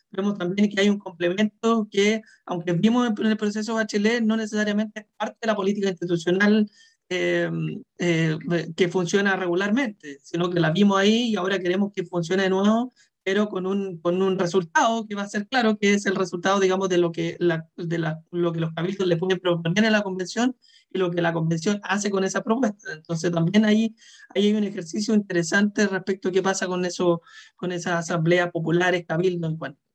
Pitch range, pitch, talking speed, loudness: 175-210 Hz, 190 Hz, 200 wpm, -23 LUFS